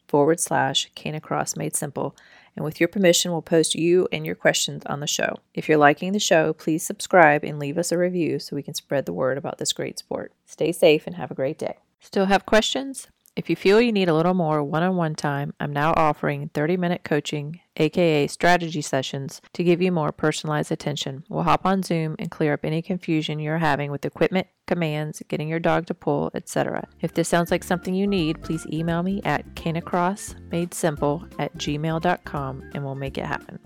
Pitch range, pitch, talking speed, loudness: 150-180 Hz, 165 Hz, 210 wpm, -23 LUFS